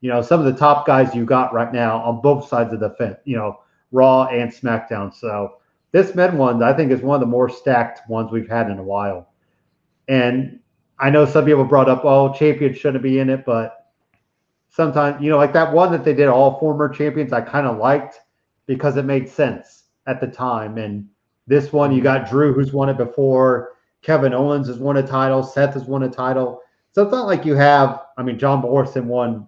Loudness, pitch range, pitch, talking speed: -17 LUFS, 120-145 Hz, 130 Hz, 220 wpm